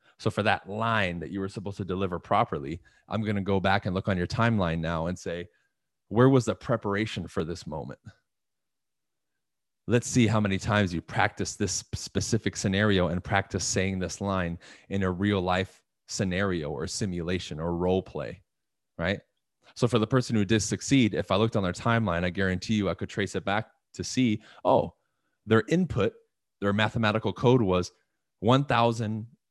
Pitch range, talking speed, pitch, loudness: 95-115 Hz, 180 wpm, 100 Hz, -27 LUFS